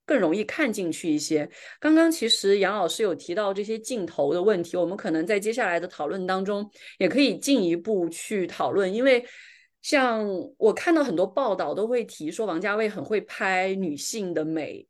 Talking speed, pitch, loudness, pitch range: 285 characters per minute, 210 Hz, -25 LUFS, 185-245 Hz